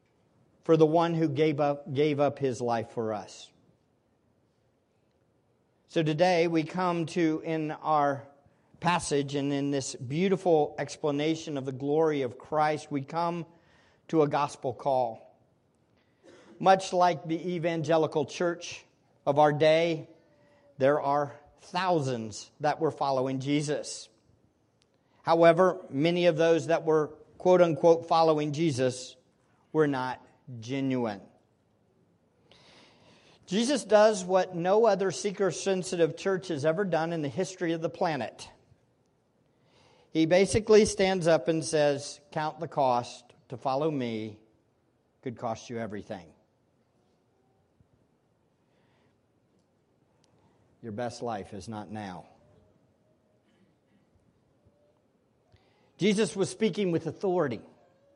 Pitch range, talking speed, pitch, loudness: 135-170 Hz, 110 wpm, 155 Hz, -28 LUFS